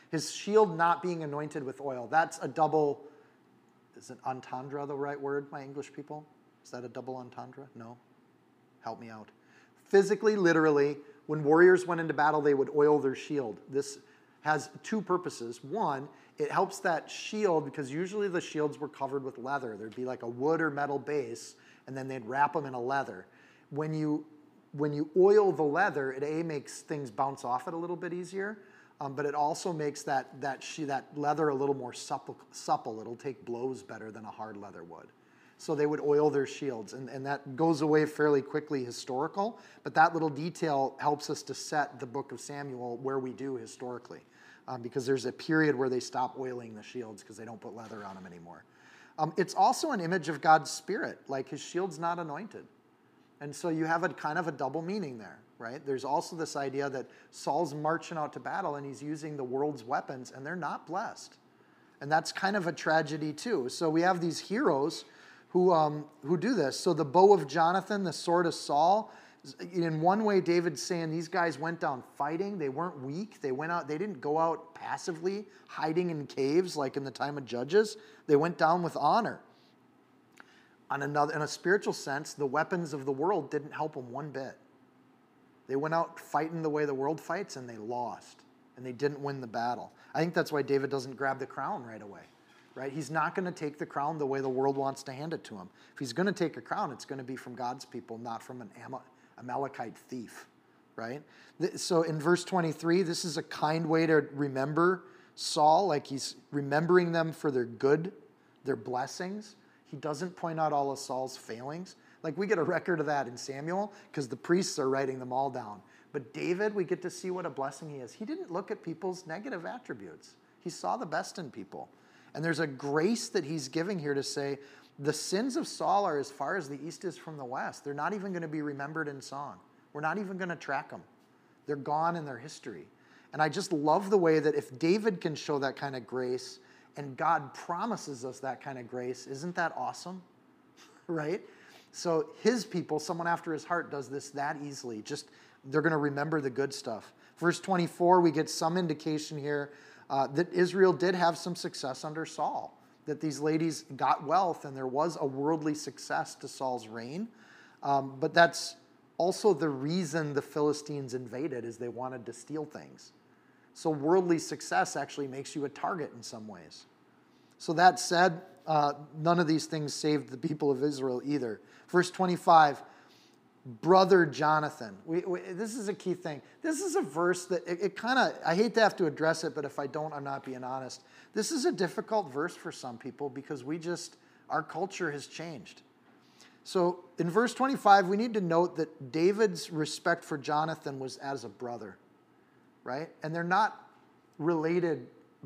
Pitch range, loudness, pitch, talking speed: 140-170 Hz, -31 LUFS, 150 Hz, 200 wpm